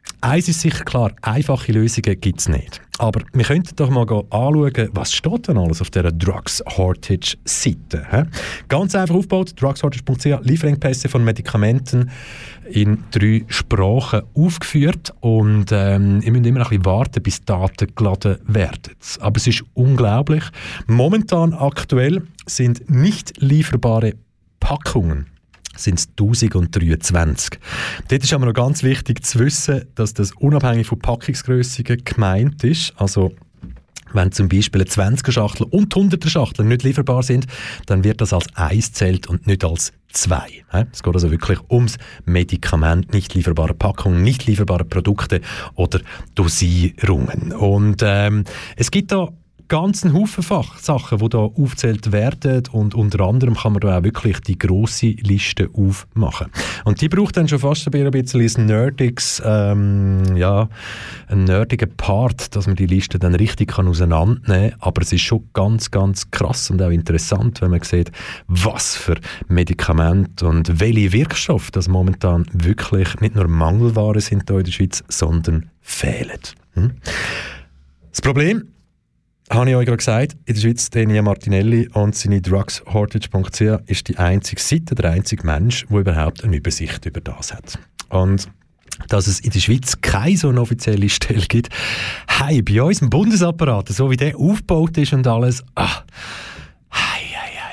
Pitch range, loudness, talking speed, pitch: 95-130 Hz, -17 LUFS, 150 wpm, 110 Hz